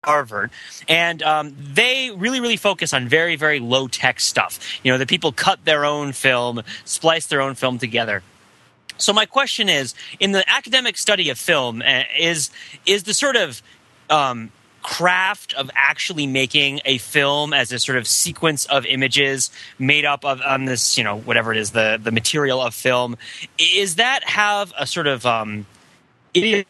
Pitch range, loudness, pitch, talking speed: 125-170 Hz, -18 LUFS, 140 Hz, 175 wpm